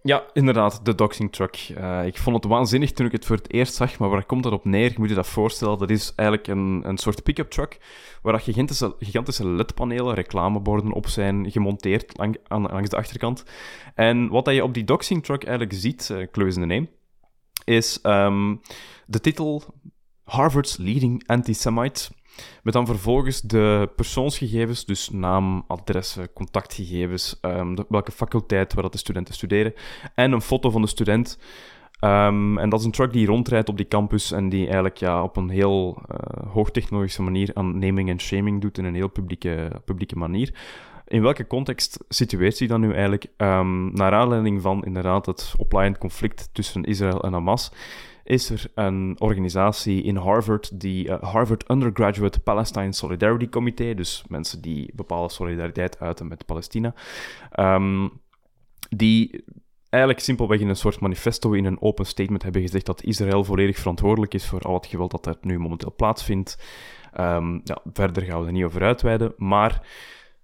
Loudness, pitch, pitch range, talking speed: -23 LUFS, 105 Hz, 95-115 Hz, 180 wpm